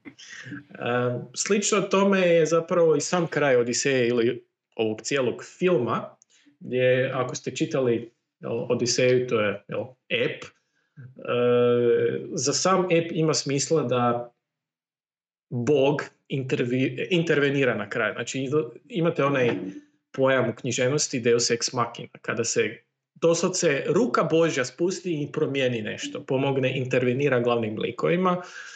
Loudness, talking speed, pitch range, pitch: -24 LUFS, 120 wpm, 125-165 Hz, 140 Hz